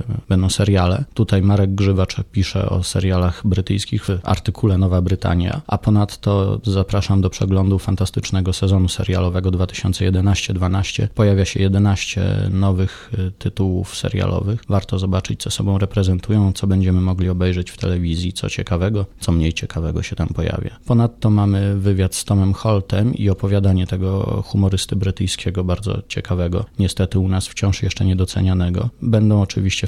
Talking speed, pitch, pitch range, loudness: 135 wpm, 95 Hz, 95-105 Hz, -19 LUFS